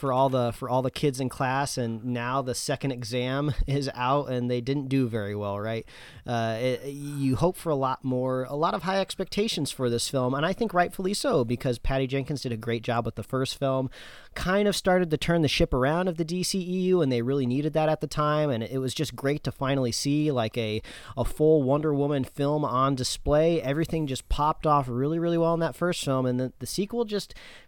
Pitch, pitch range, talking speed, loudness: 140 Hz, 125-155 Hz, 230 wpm, -27 LUFS